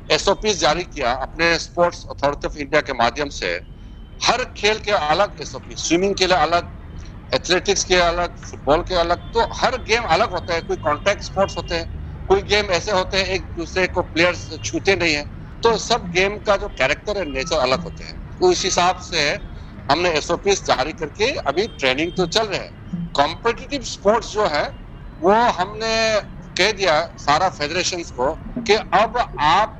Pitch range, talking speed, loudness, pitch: 150-195 Hz, 165 wpm, -20 LUFS, 175 Hz